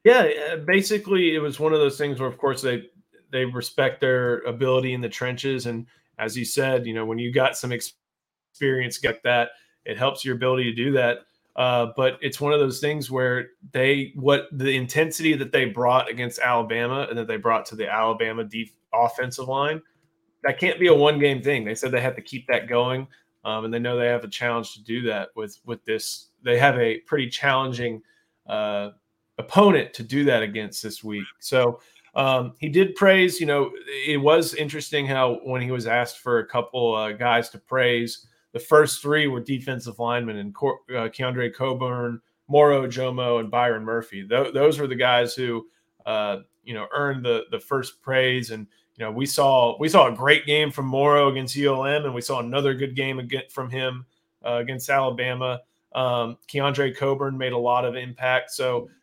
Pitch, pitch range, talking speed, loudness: 130 Hz, 120-140 Hz, 195 wpm, -23 LUFS